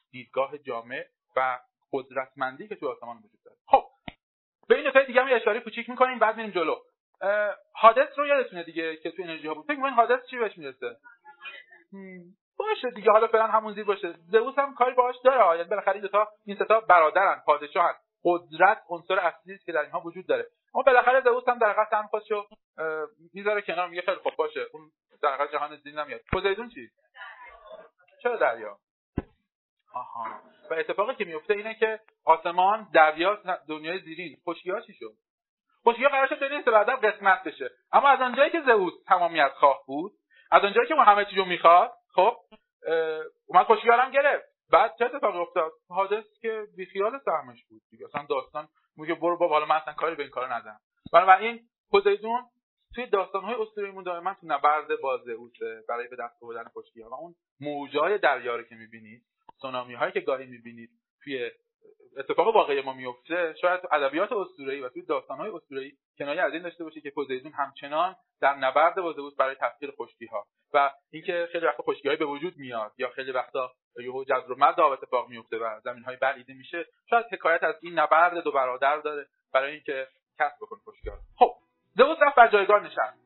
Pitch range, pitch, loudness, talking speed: 155-245 Hz, 195 Hz, -25 LUFS, 180 wpm